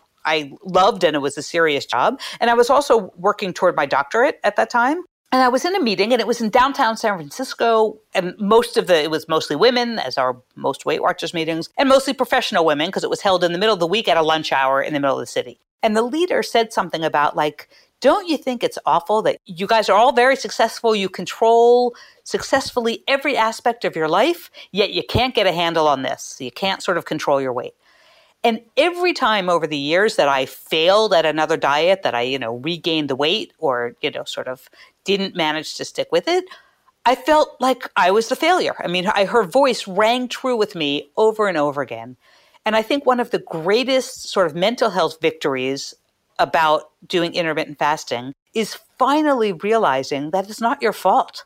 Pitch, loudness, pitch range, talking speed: 210 Hz, -19 LUFS, 160-250 Hz, 220 wpm